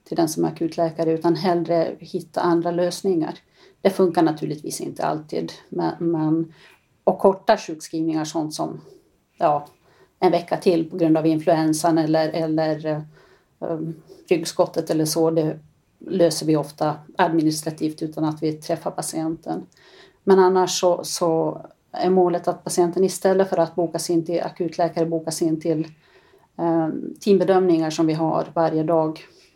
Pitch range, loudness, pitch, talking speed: 160-180 Hz, -22 LUFS, 165 Hz, 145 wpm